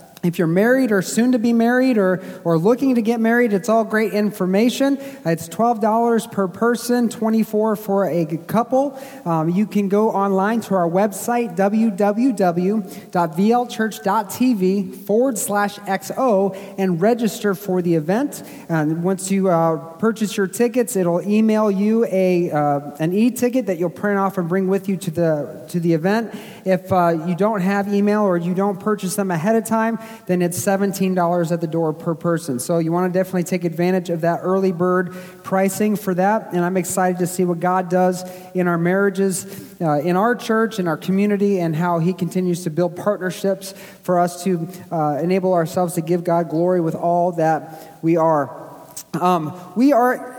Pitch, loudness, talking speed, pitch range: 190 Hz, -19 LUFS, 175 wpm, 175-215 Hz